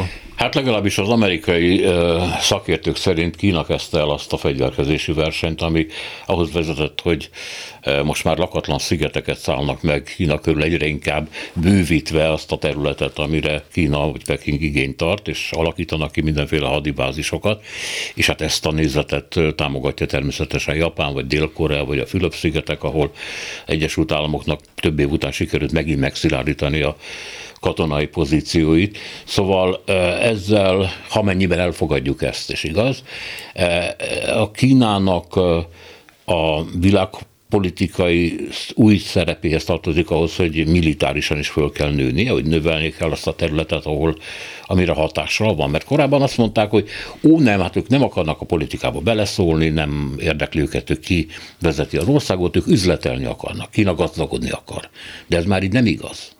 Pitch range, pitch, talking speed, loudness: 75-95 Hz, 85 Hz, 145 wpm, -19 LUFS